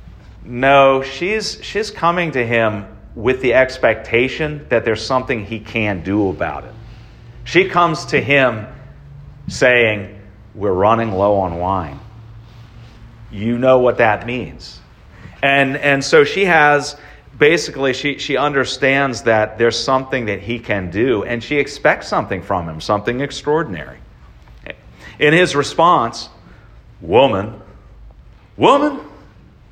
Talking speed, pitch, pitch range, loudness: 125 wpm, 120 Hz, 105-140 Hz, -16 LUFS